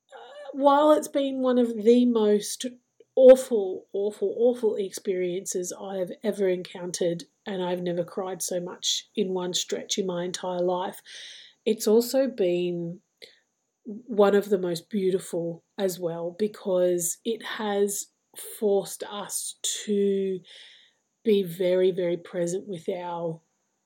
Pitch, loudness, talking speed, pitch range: 200 Hz, -26 LUFS, 125 wpm, 180-245 Hz